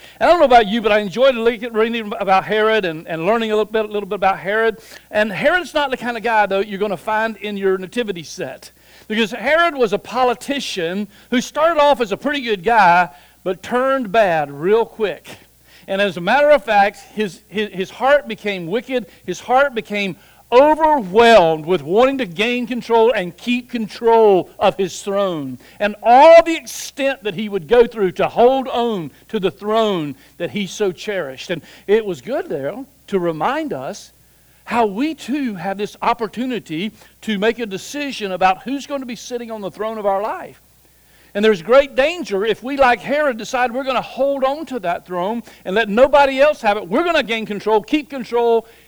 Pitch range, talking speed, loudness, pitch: 200-255 Hz, 200 wpm, -17 LUFS, 220 Hz